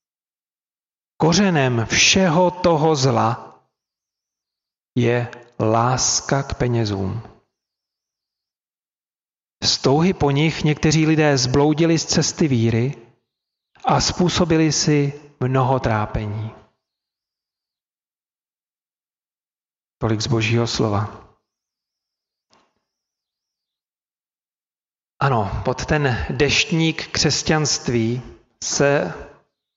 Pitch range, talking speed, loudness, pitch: 115-155 Hz, 65 wpm, -19 LUFS, 130 Hz